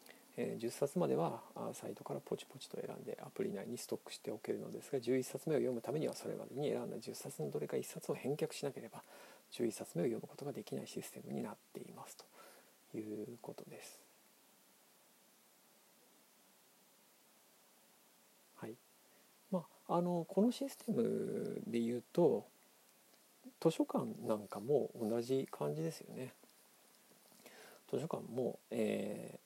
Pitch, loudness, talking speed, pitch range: 180 Hz, -41 LUFS, 225 characters per minute, 130-215 Hz